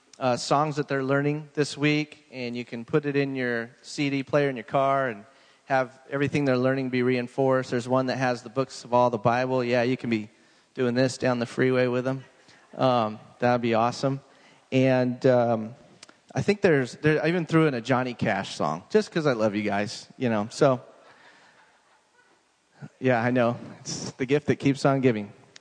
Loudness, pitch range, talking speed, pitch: -25 LUFS, 120-140 Hz, 195 wpm, 130 Hz